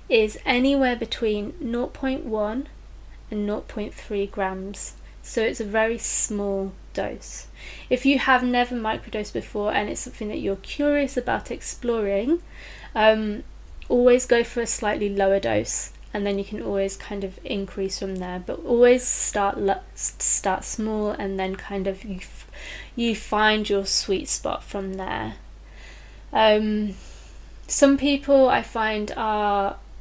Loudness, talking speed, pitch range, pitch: -23 LUFS, 140 wpm, 200-245 Hz, 215 Hz